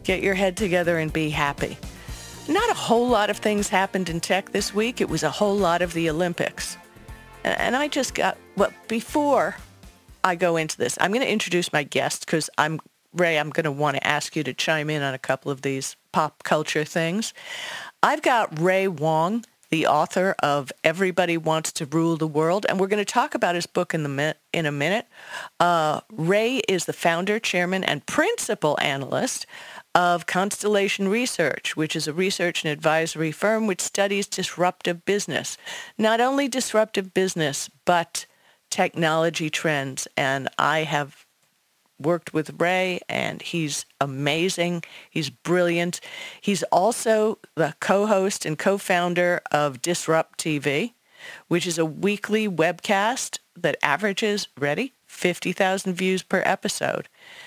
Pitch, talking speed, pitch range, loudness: 175 Hz, 160 wpm, 160-200 Hz, -23 LUFS